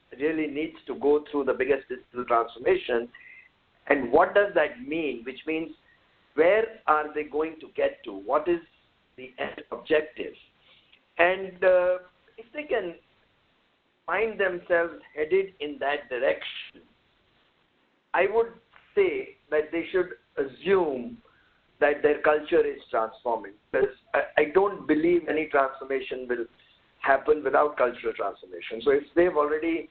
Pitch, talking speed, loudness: 175 Hz, 135 wpm, -26 LUFS